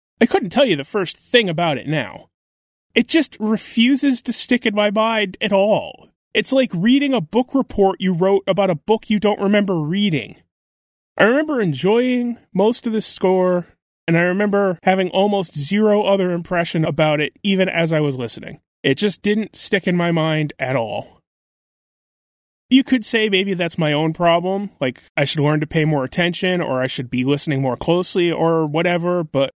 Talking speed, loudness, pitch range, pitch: 185 wpm, -18 LUFS, 155-215 Hz, 185 Hz